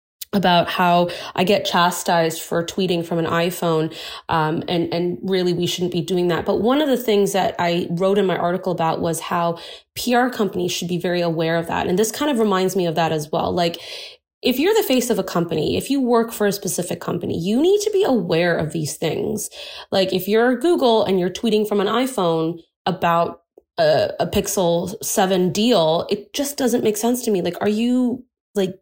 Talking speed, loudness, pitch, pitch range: 210 wpm, -20 LUFS, 190 Hz, 170-230 Hz